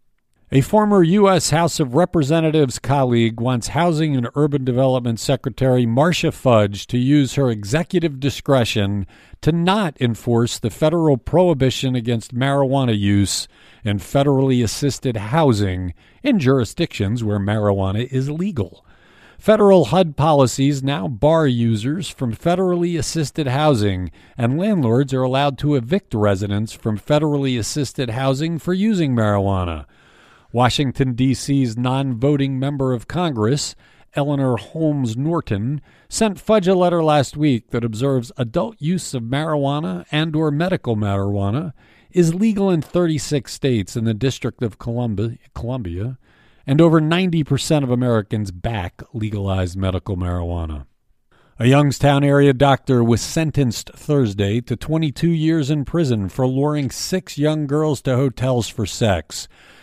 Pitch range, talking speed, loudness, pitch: 115-155 Hz, 130 wpm, -19 LUFS, 135 Hz